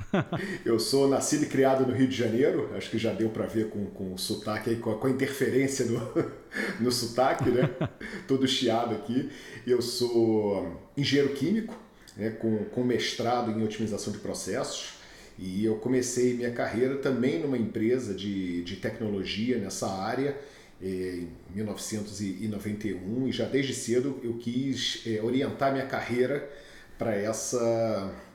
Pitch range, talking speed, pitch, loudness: 110-130 Hz, 145 wpm, 115 Hz, -29 LUFS